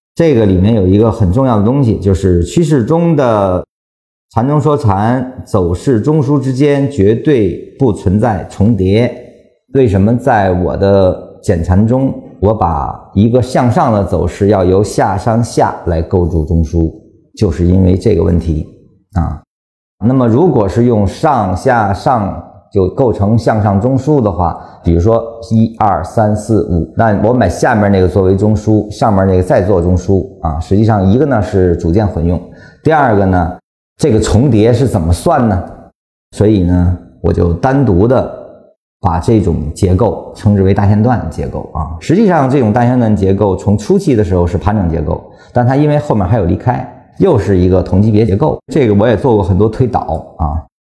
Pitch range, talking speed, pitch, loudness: 90-115 Hz, 255 characters per minute, 100 Hz, -12 LUFS